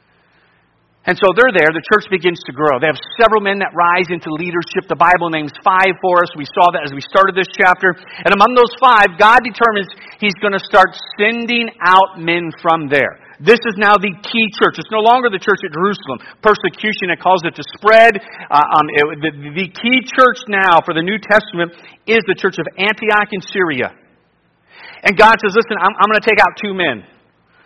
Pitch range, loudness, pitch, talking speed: 170-215 Hz, -13 LUFS, 190 Hz, 210 wpm